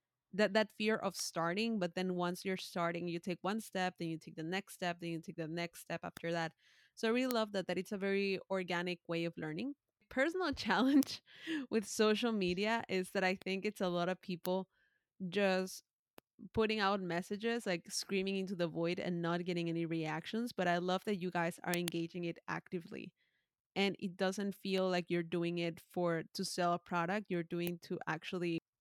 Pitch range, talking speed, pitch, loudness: 170-200 Hz, 200 wpm, 185 Hz, -38 LUFS